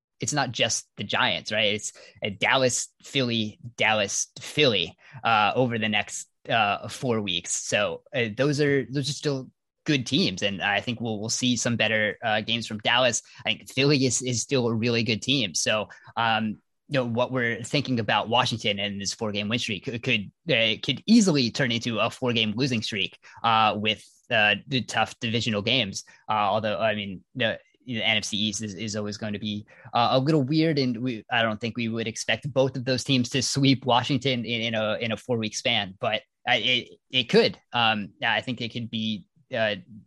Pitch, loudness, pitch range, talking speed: 115 Hz, -25 LUFS, 110-130 Hz, 205 wpm